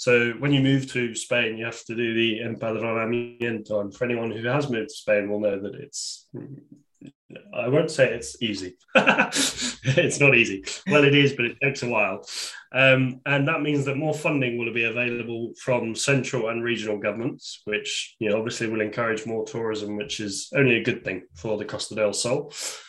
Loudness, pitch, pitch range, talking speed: -24 LUFS, 115 Hz, 110-130 Hz, 195 wpm